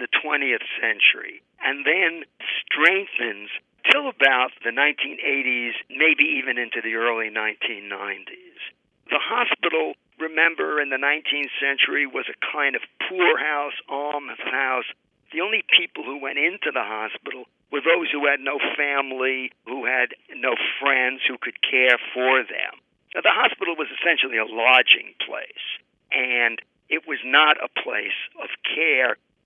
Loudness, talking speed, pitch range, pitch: -21 LUFS, 140 wpm, 130-160 Hz, 140 Hz